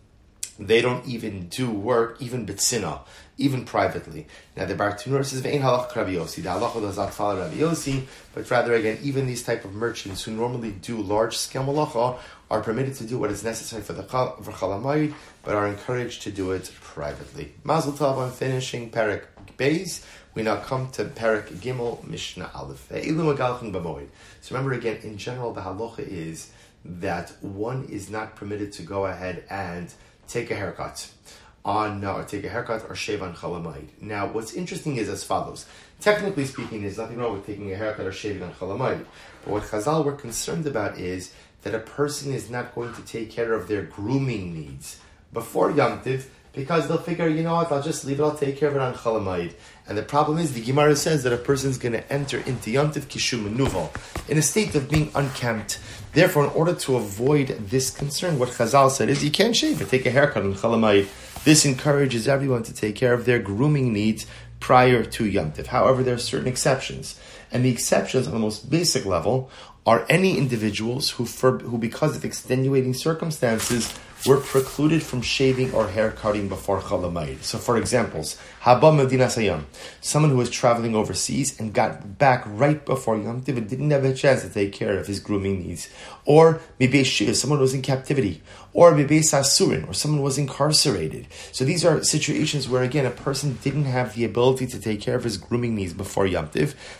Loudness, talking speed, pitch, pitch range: -23 LUFS, 185 wpm, 125 Hz, 105-140 Hz